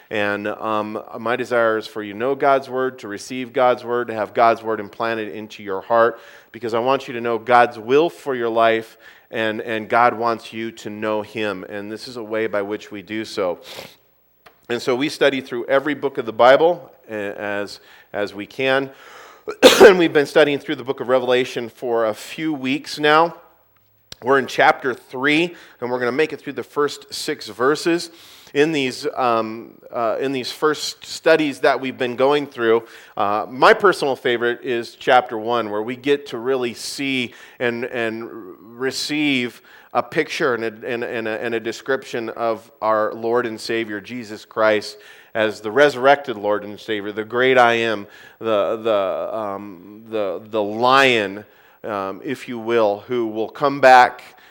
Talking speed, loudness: 180 wpm, -19 LUFS